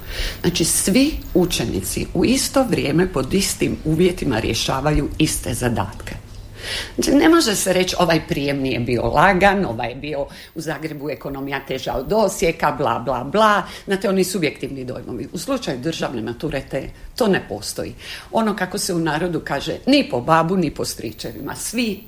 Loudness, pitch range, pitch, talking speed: -20 LUFS, 130-190 Hz, 155 Hz, 160 wpm